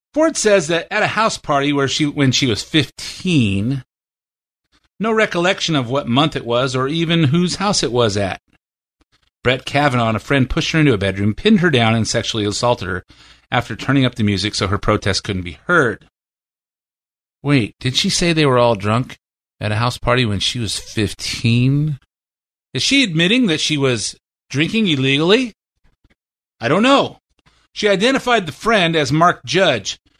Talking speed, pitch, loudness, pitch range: 175 wpm, 130 Hz, -17 LUFS, 105-160 Hz